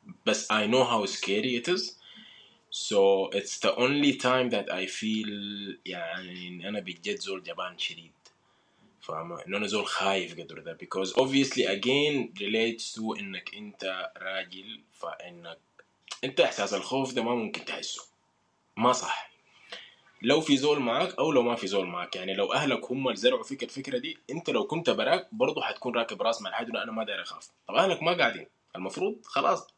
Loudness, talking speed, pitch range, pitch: -29 LUFS, 170 wpm, 95-145 Hz, 120 Hz